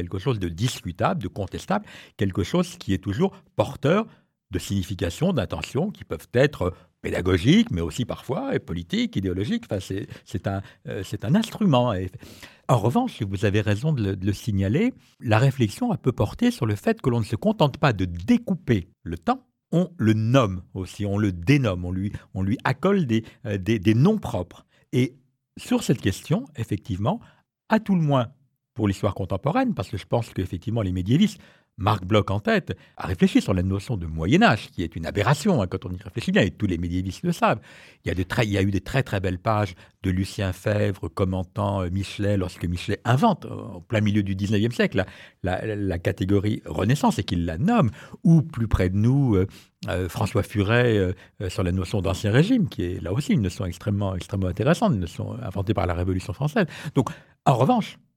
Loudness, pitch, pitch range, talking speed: -24 LUFS, 105 Hz, 95-130 Hz, 205 wpm